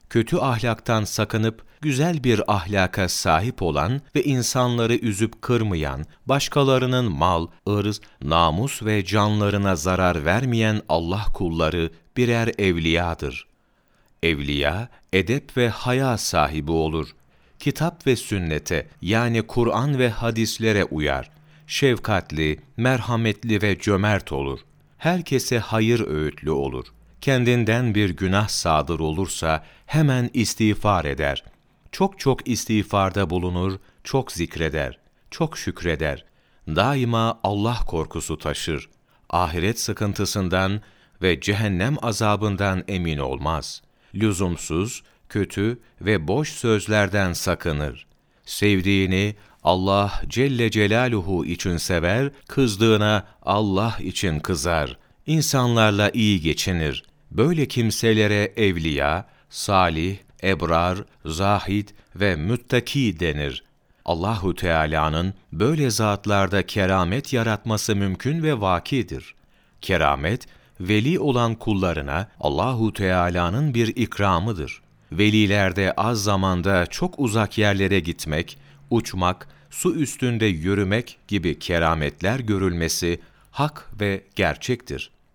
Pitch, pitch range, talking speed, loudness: 105 Hz, 85-115 Hz, 95 wpm, -22 LUFS